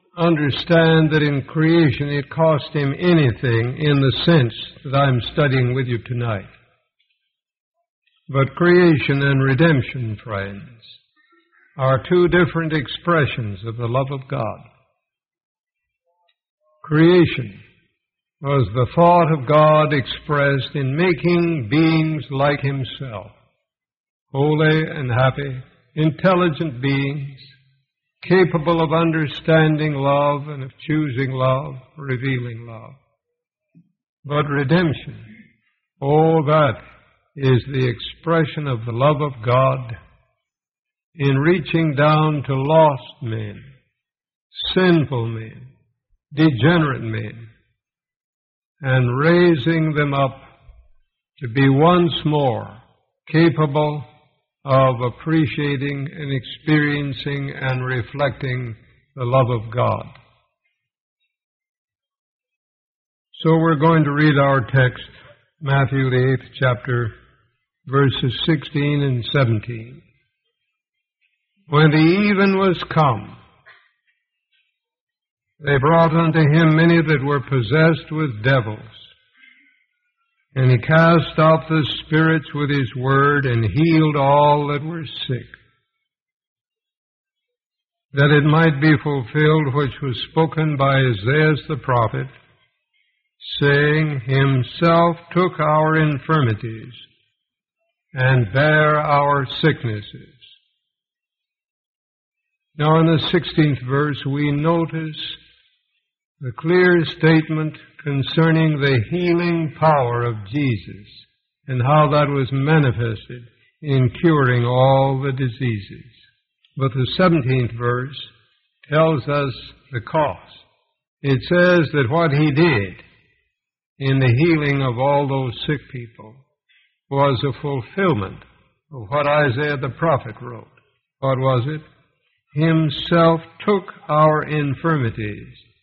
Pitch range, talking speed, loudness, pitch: 130-160 Hz, 100 wpm, -18 LUFS, 145 Hz